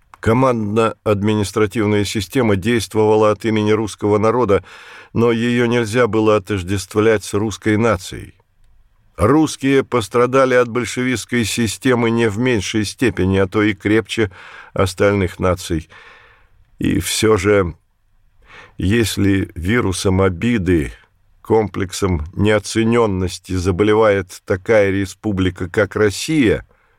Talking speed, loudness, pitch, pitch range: 95 wpm, -17 LUFS, 105 Hz, 100-115 Hz